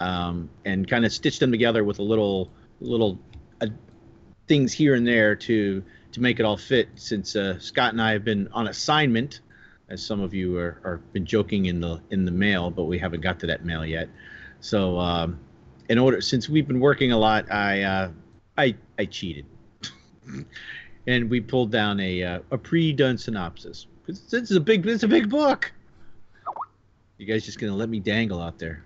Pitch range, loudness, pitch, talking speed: 90-120 Hz, -24 LUFS, 105 Hz, 200 wpm